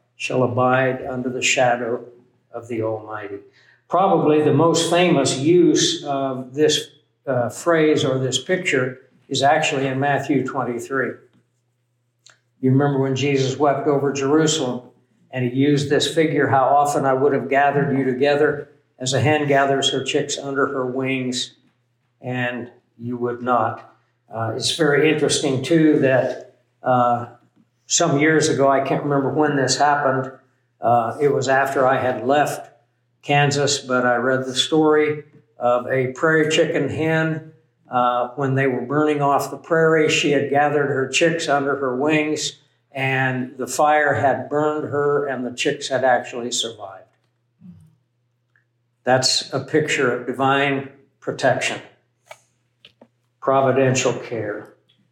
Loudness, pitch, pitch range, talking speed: -19 LUFS, 135 Hz, 125-145 Hz, 140 wpm